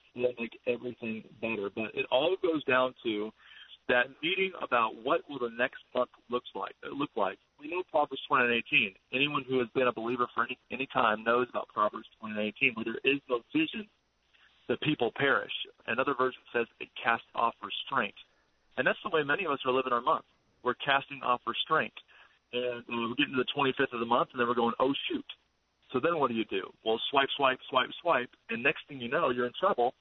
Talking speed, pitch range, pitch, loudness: 210 wpm, 120-135 Hz, 125 Hz, -31 LUFS